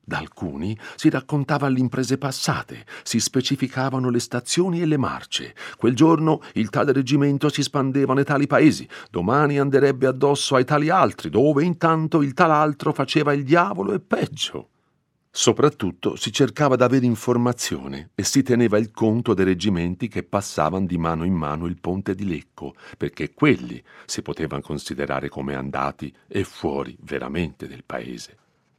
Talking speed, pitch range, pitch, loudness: 155 wpm, 95-145 Hz, 130 Hz, -21 LUFS